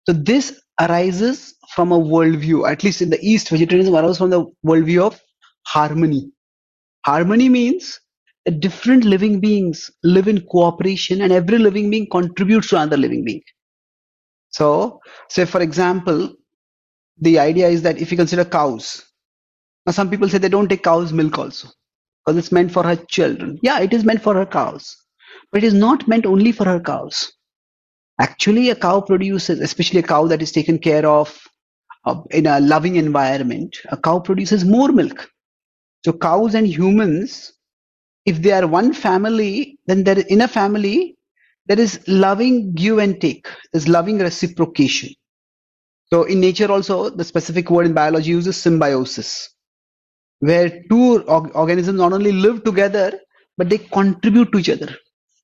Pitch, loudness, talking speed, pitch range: 185 Hz, -16 LUFS, 160 wpm, 165-210 Hz